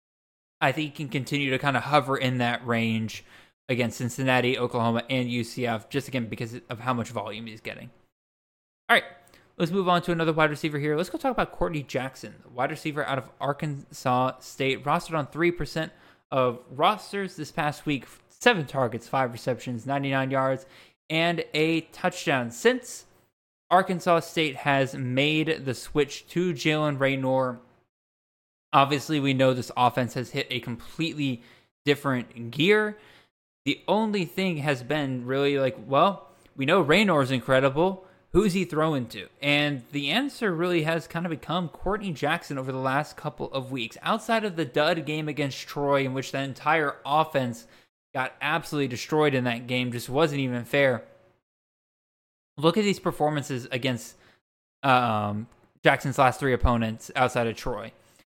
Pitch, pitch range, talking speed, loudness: 140 Hz, 125-160 Hz, 160 wpm, -26 LUFS